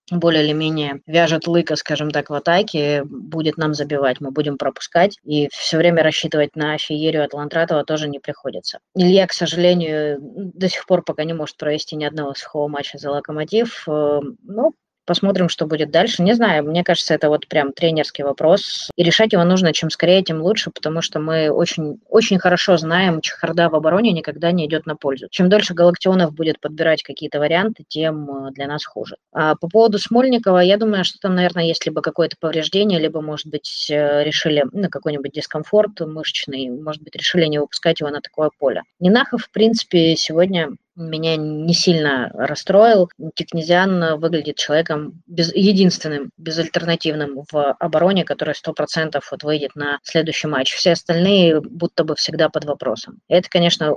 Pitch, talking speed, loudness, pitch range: 160 Hz, 170 wpm, -18 LUFS, 150-175 Hz